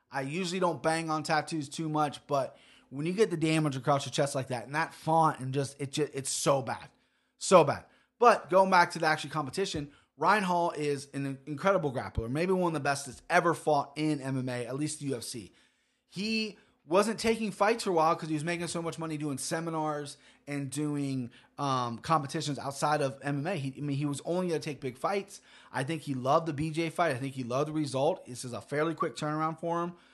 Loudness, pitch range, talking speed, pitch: -30 LUFS, 140-165 Hz, 225 wpm, 150 Hz